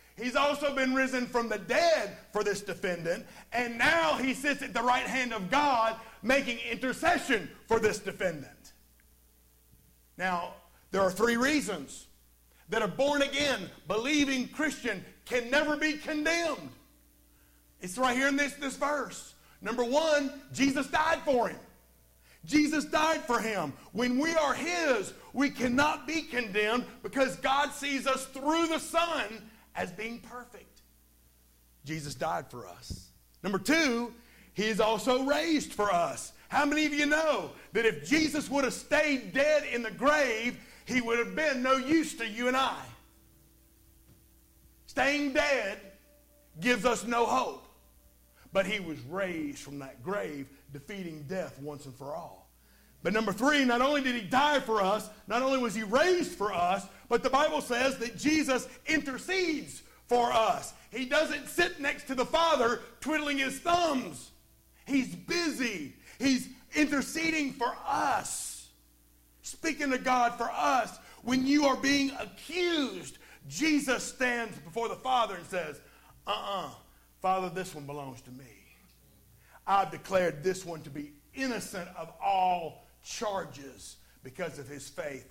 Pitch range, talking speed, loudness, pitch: 185-285 Hz, 150 wpm, -30 LUFS, 245 Hz